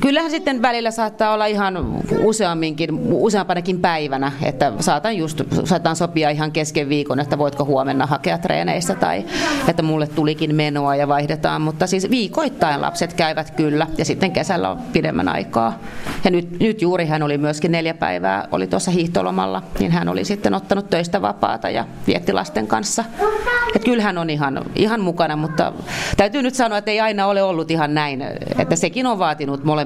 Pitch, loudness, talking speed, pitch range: 170 Hz, -19 LUFS, 170 wpm, 150-205 Hz